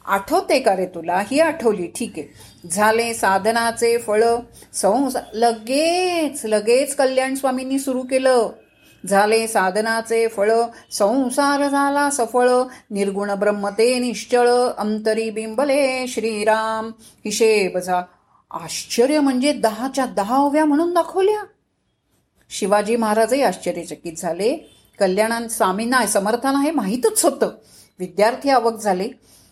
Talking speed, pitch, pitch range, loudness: 95 wpm, 230 Hz, 210-265 Hz, -19 LUFS